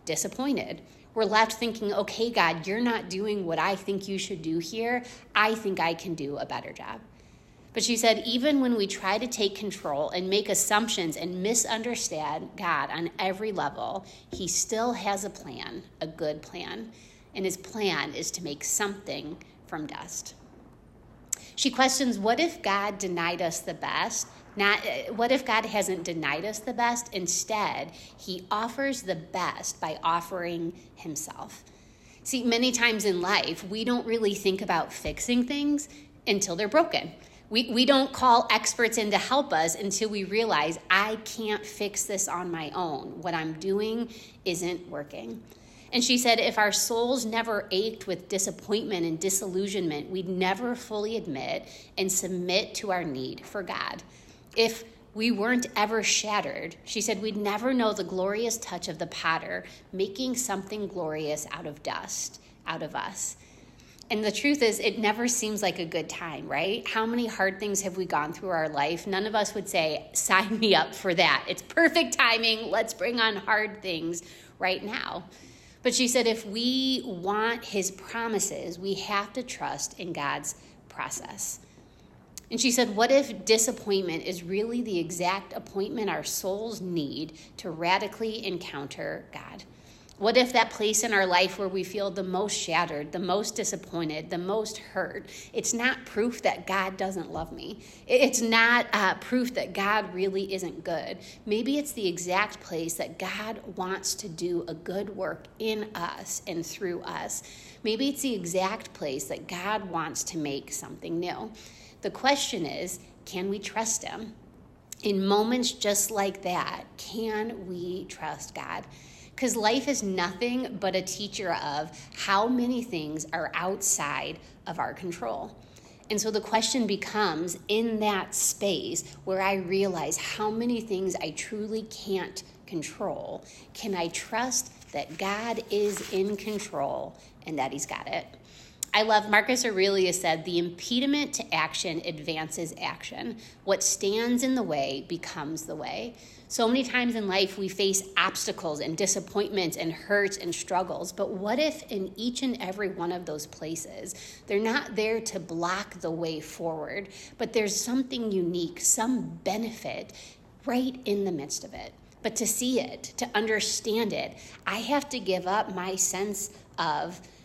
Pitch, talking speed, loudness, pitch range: 200 Hz, 165 wpm, -28 LUFS, 180-225 Hz